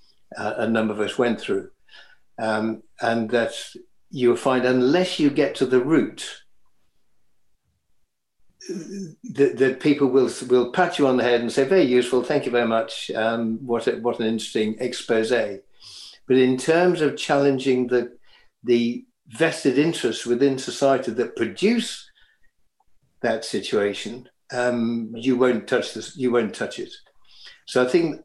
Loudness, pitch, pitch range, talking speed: -22 LUFS, 125 Hz, 120-145 Hz, 150 wpm